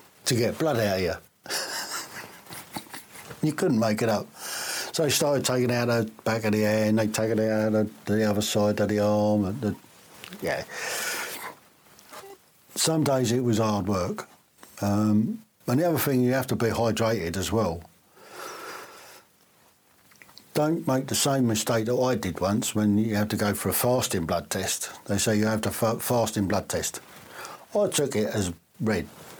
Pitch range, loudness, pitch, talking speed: 105-135 Hz, -26 LUFS, 115 Hz, 180 wpm